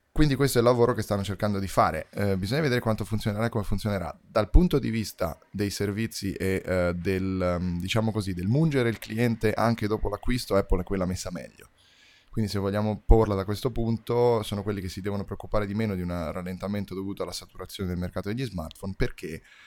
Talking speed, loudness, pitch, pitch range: 205 wpm, -27 LUFS, 105 Hz, 95-115 Hz